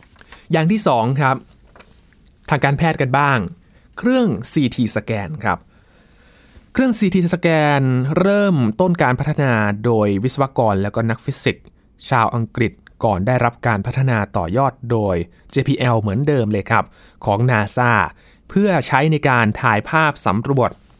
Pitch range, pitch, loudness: 110-150 Hz, 125 Hz, -18 LUFS